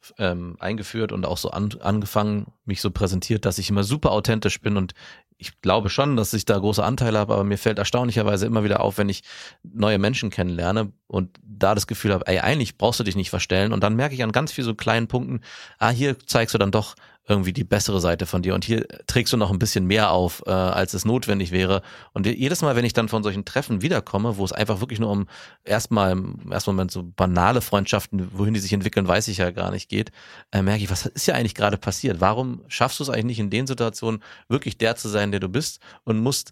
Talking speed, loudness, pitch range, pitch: 240 wpm, -23 LUFS, 95-115 Hz, 105 Hz